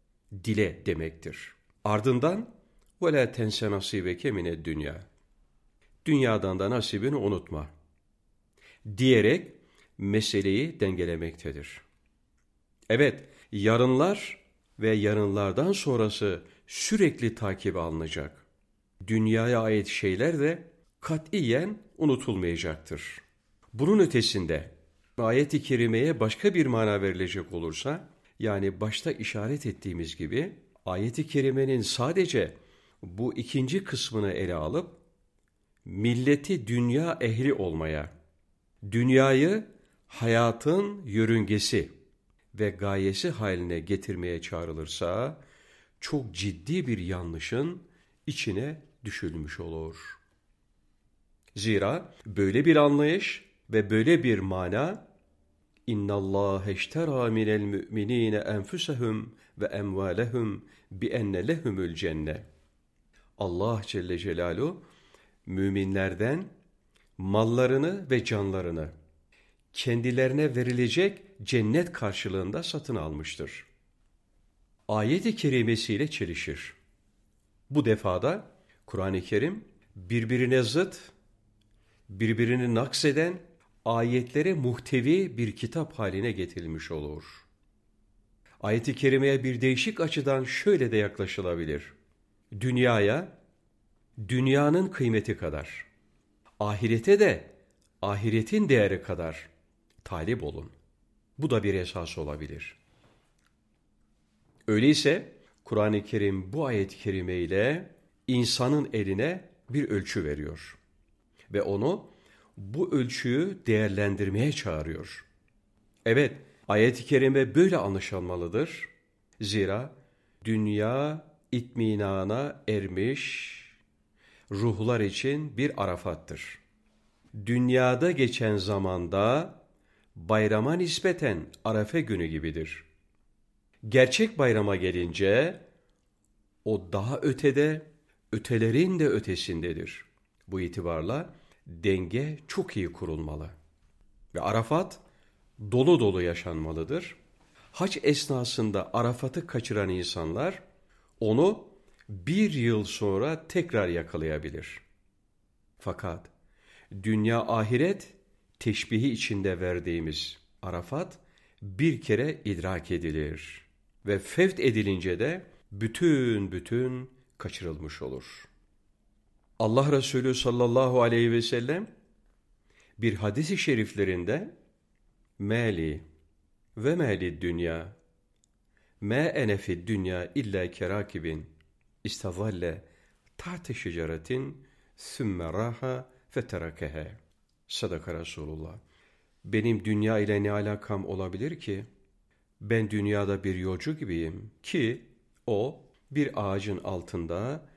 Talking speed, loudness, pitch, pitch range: 85 wpm, -28 LUFS, 105 Hz, 95-130 Hz